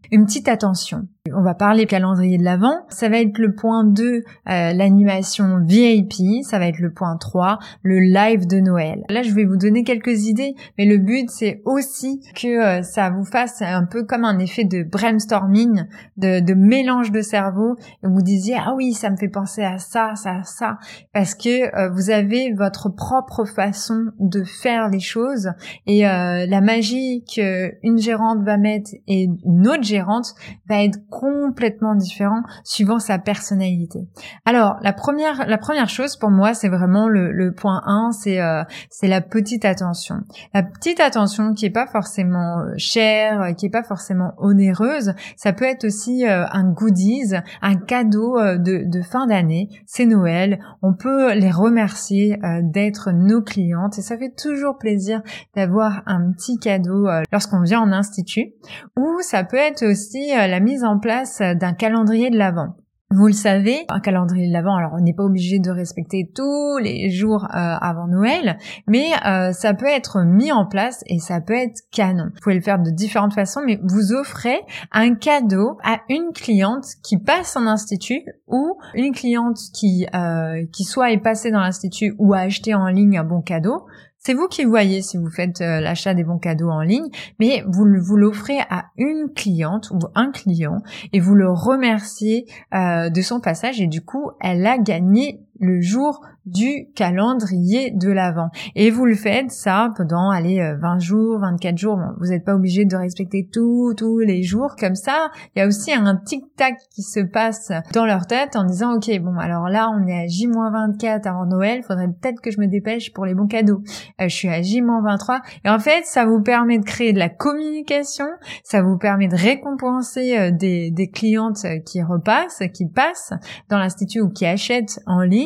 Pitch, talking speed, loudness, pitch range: 205 Hz, 190 wpm, -18 LUFS, 185-230 Hz